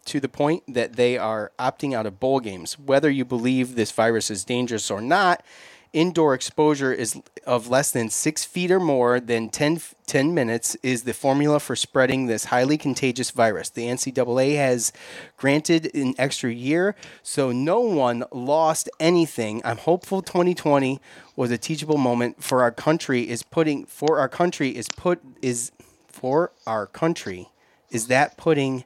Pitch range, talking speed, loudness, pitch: 120-150 Hz, 165 wpm, -23 LUFS, 130 Hz